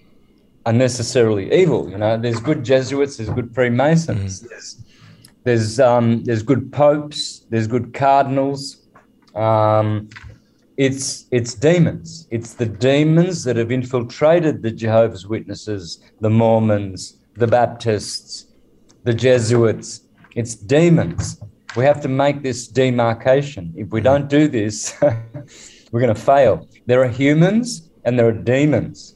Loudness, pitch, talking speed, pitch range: -17 LUFS, 120 Hz, 130 wpm, 110-140 Hz